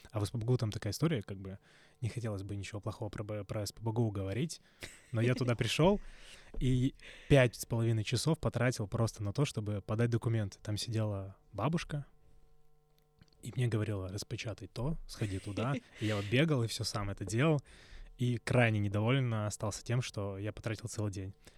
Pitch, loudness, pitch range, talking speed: 115 Hz, -35 LUFS, 105-130 Hz, 170 wpm